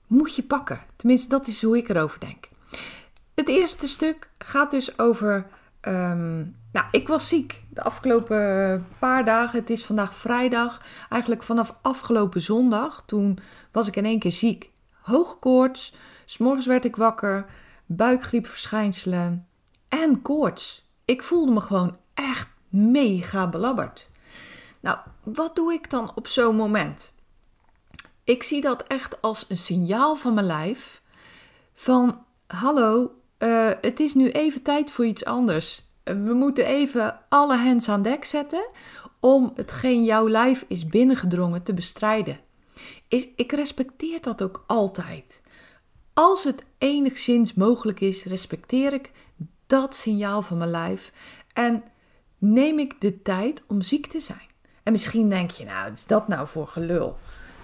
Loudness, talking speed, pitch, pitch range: -23 LUFS, 145 wpm, 230 Hz, 200-265 Hz